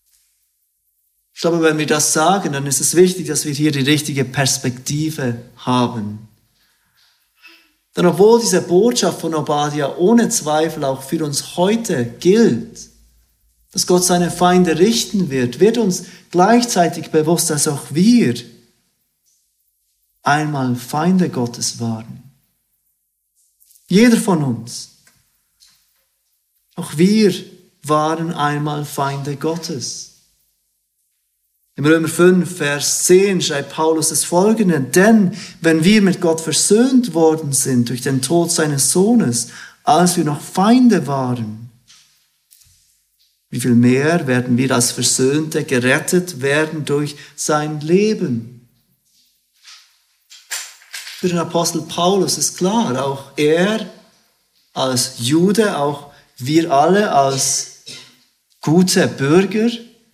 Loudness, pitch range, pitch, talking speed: -16 LUFS, 135-180 Hz, 155 Hz, 110 wpm